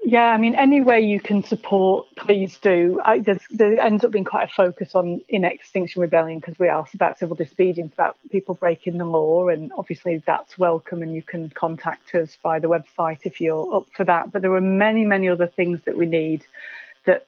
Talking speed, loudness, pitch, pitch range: 210 wpm, -21 LUFS, 180 Hz, 170-200 Hz